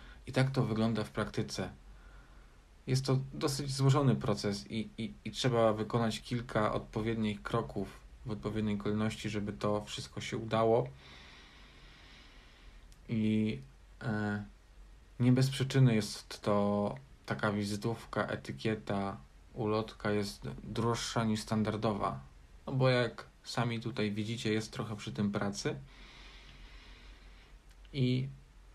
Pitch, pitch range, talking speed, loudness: 110 Hz, 100-115 Hz, 115 wpm, -34 LUFS